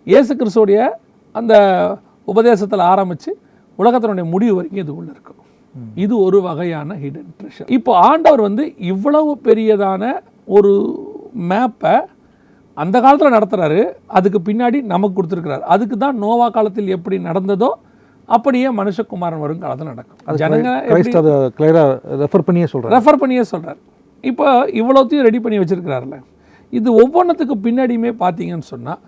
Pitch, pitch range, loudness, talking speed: 210 Hz, 180-245 Hz, -14 LUFS, 110 wpm